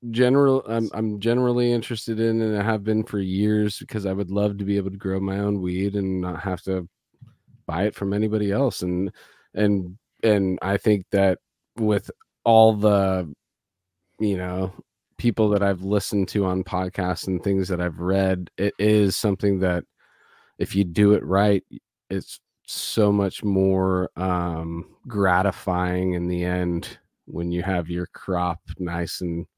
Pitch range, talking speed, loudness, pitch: 90-105 Hz, 165 wpm, -23 LUFS, 100 Hz